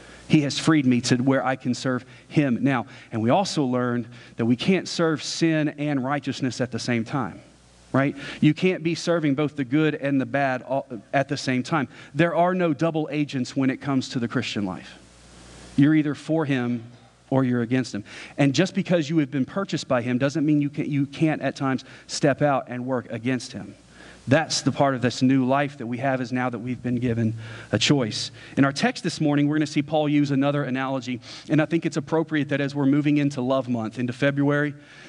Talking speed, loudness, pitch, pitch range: 220 wpm, -24 LUFS, 135 Hz, 125-150 Hz